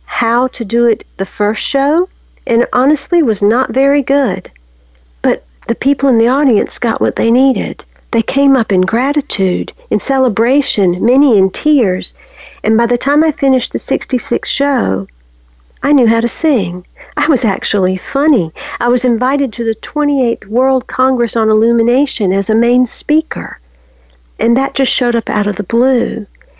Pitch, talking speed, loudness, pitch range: 240 Hz, 165 wpm, -12 LUFS, 210-270 Hz